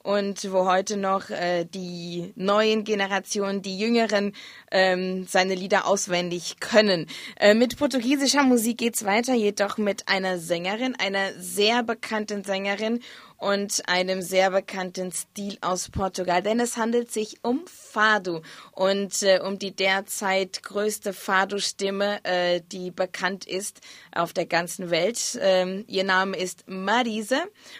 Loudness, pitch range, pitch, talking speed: -24 LUFS, 185-215 Hz, 195 Hz, 135 wpm